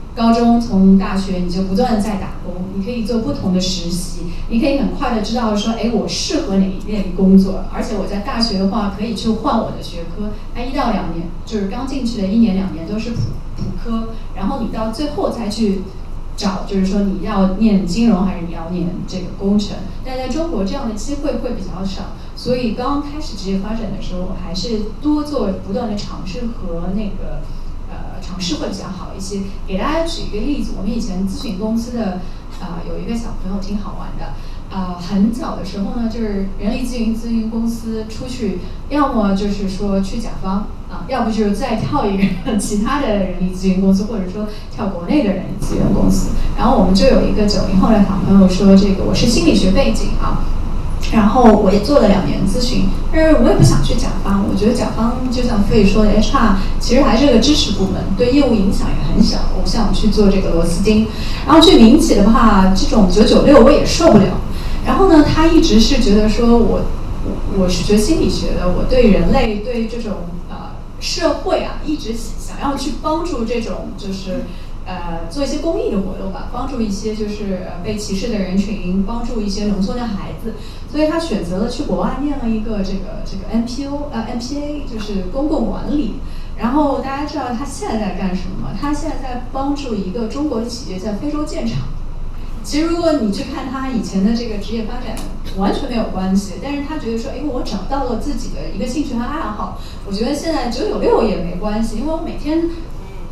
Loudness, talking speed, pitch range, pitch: -17 LUFS, 310 characters per minute, 195-250 Hz, 220 Hz